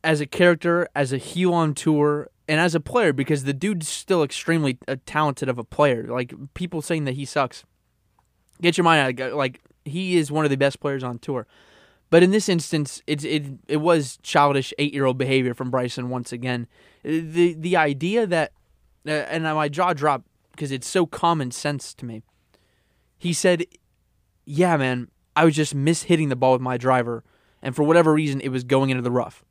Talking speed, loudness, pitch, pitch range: 205 wpm, -22 LUFS, 145 Hz, 130-165 Hz